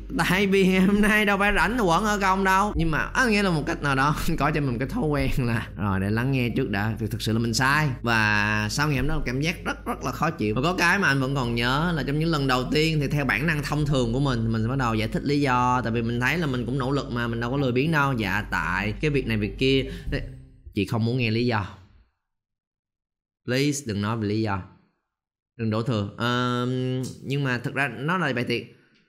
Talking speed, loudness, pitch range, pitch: 265 wpm, -24 LUFS, 115-150 Hz, 130 Hz